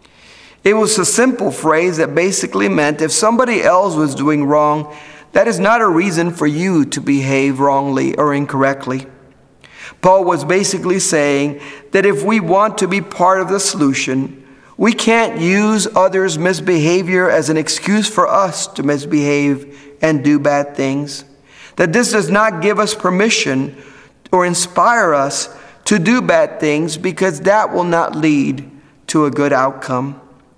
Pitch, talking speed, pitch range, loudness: 155 Hz, 155 wpm, 140-190 Hz, -14 LUFS